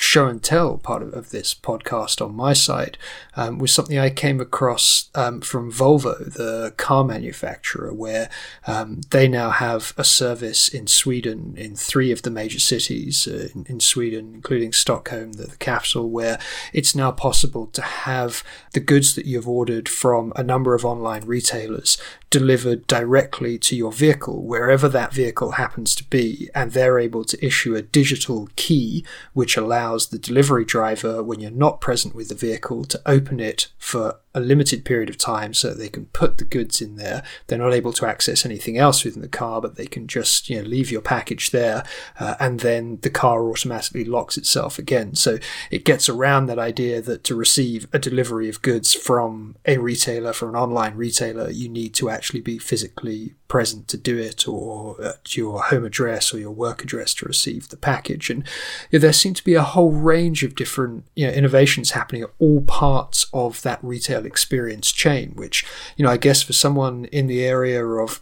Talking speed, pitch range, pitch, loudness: 190 wpm, 115-135 Hz, 125 Hz, -20 LUFS